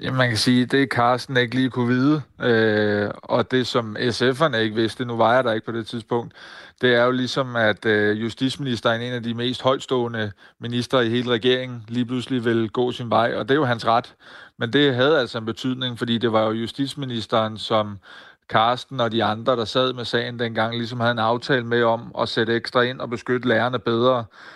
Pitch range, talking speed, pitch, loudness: 115-125 Hz, 215 wpm, 120 Hz, -21 LUFS